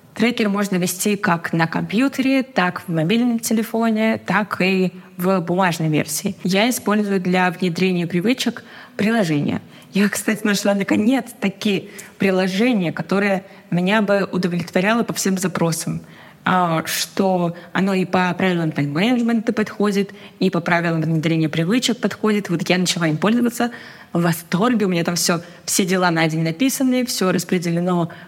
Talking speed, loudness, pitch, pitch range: 140 wpm, -19 LUFS, 190 Hz, 175-215 Hz